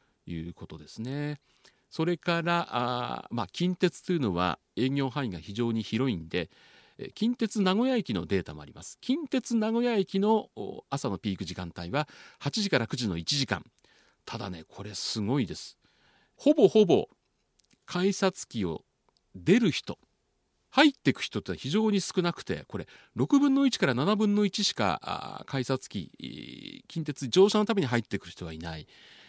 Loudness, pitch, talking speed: -29 LUFS, 145 Hz, 290 characters per minute